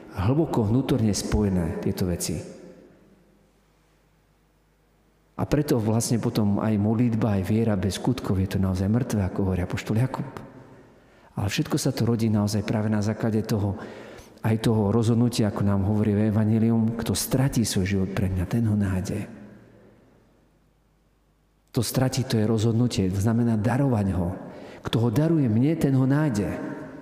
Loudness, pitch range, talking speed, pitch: -24 LUFS, 100-120 Hz, 145 wpm, 110 Hz